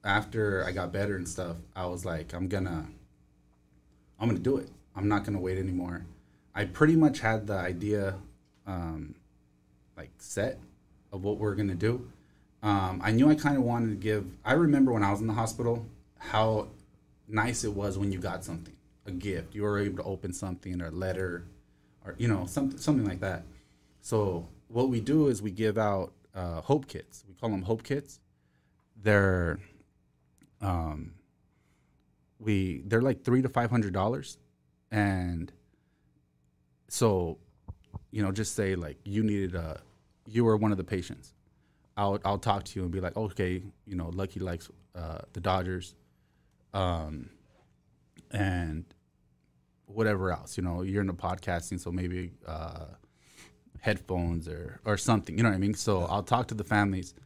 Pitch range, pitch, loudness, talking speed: 85-105 Hz, 95 Hz, -31 LUFS, 170 wpm